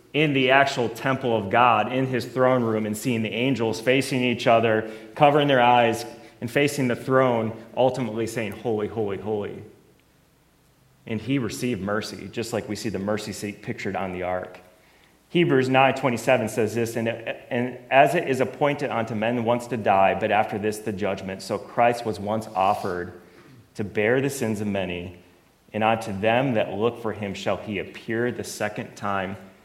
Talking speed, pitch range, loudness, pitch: 180 wpm, 105-125 Hz, -24 LUFS, 115 Hz